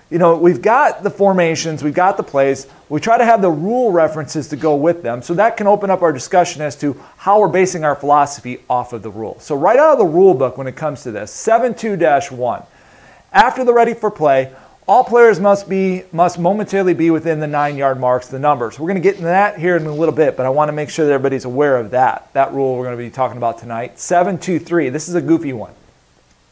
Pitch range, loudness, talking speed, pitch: 135-185 Hz, -15 LUFS, 255 wpm, 160 Hz